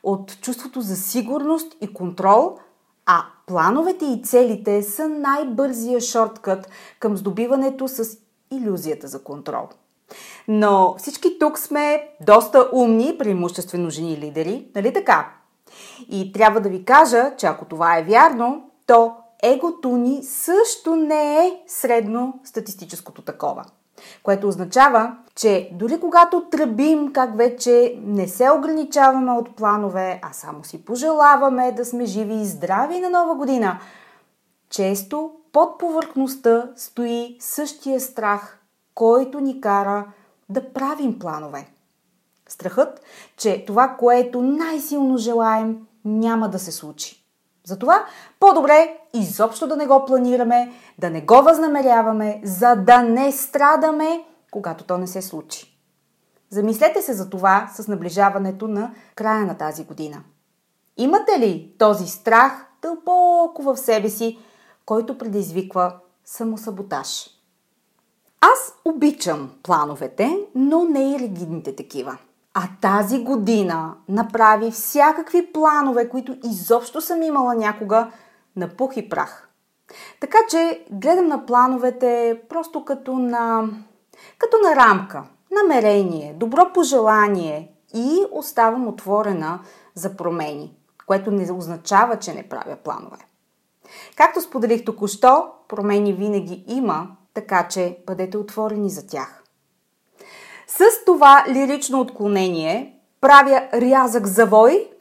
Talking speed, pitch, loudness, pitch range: 120 wpm, 230 Hz, -18 LUFS, 200-275 Hz